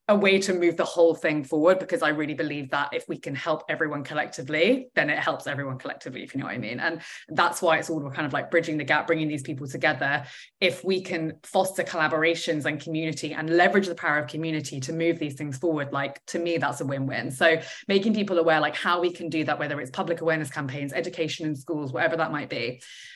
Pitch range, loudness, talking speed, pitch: 150-170 Hz, -26 LUFS, 240 wpm, 160 Hz